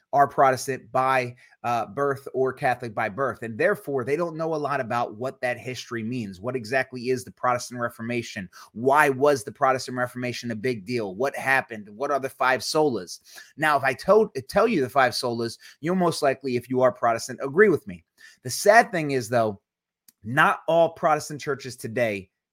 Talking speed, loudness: 190 wpm, -24 LUFS